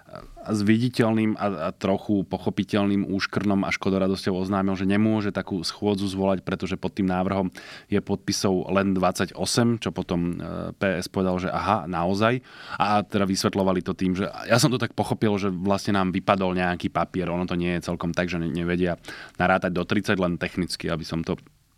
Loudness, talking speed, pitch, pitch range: -25 LUFS, 175 wpm, 95 Hz, 90-100 Hz